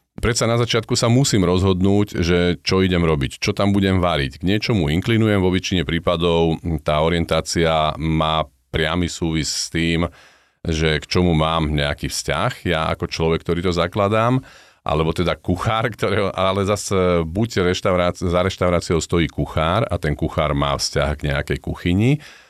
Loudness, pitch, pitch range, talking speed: -19 LUFS, 90 Hz, 80-100 Hz, 155 wpm